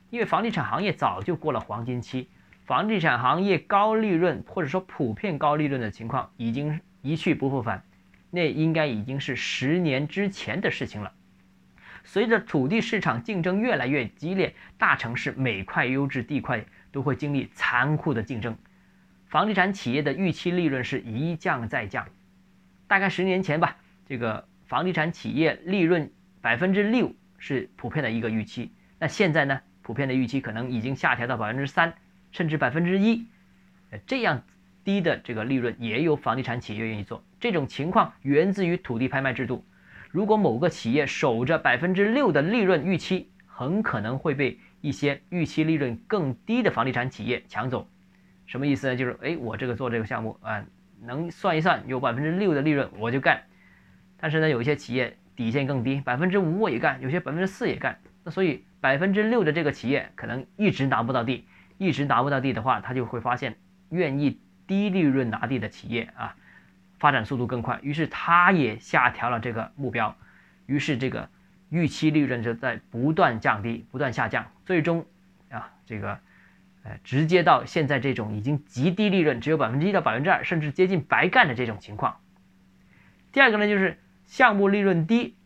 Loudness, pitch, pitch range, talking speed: -25 LUFS, 140 Hz, 120-175 Hz, 290 characters per minute